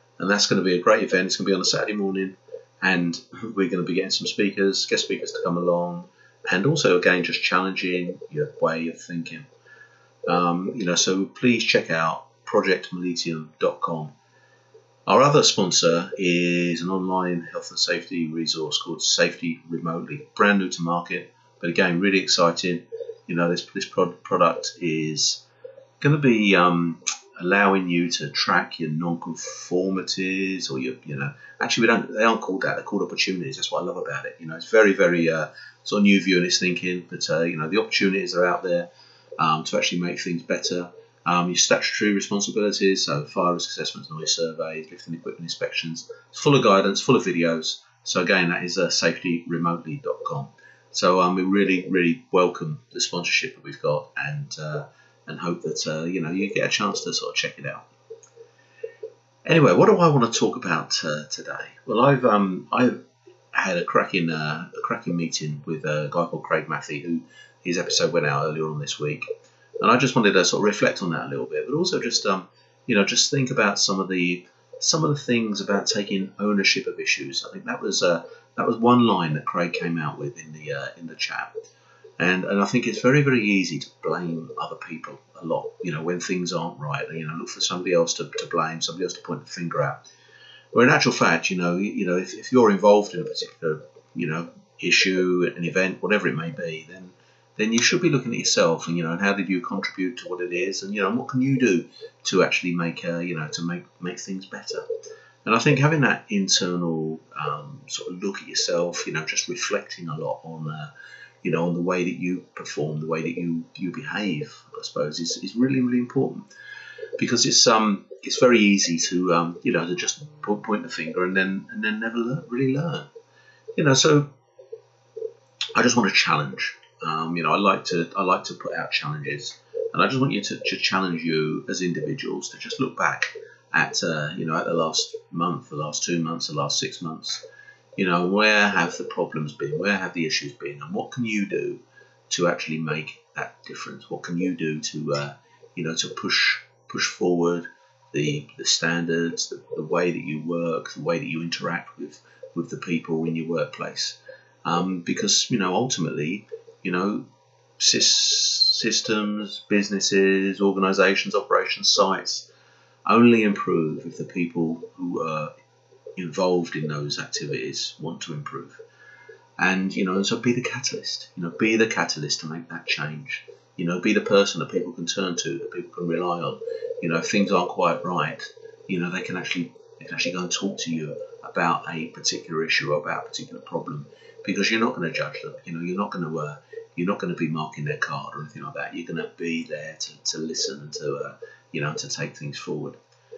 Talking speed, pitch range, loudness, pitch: 210 wpm, 85-120 Hz, -23 LUFS, 90 Hz